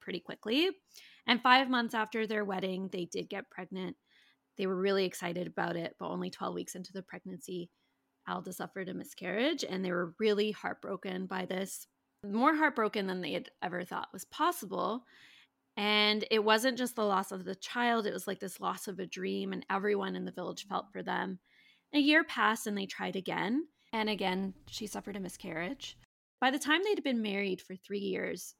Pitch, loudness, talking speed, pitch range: 200 Hz, -33 LUFS, 195 wpm, 185-230 Hz